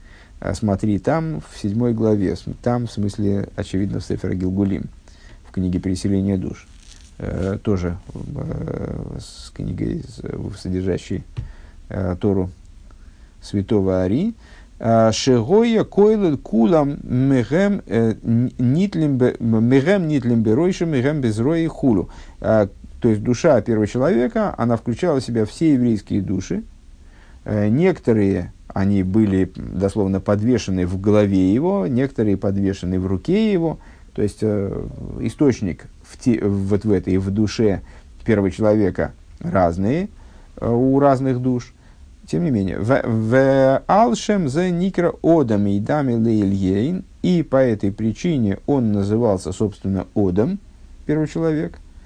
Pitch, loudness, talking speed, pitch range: 110 Hz, -19 LUFS, 110 wpm, 95-135 Hz